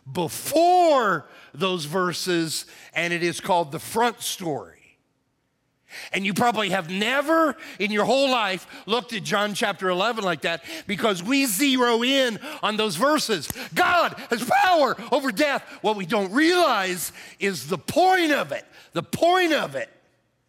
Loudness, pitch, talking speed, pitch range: -23 LUFS, 210 Hz, 150 wpm, 180-275 Hz